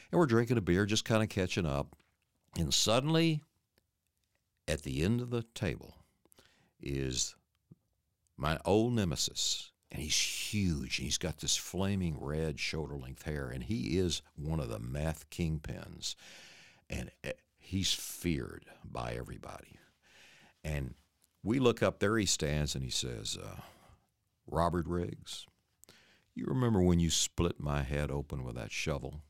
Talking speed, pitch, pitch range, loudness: 145 wpm, 85 Hz, 75-95 Hz, -34 LUFS